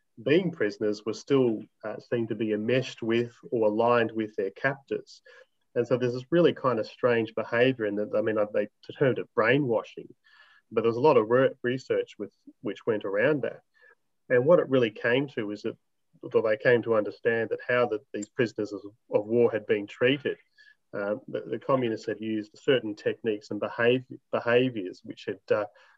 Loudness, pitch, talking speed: -27 LUFS, 120 Hz, 190 wpm